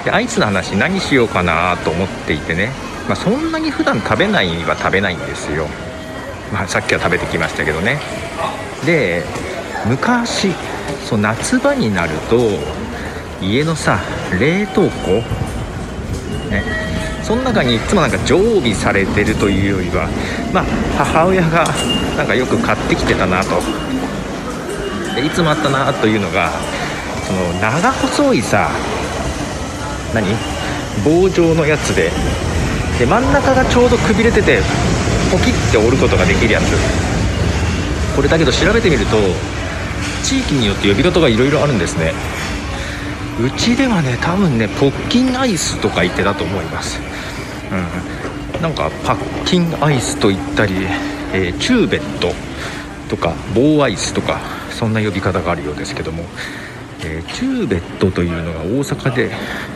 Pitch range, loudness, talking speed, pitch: 95-150 Hz, -16 LUFS, 290 characters per minute, 100 Hz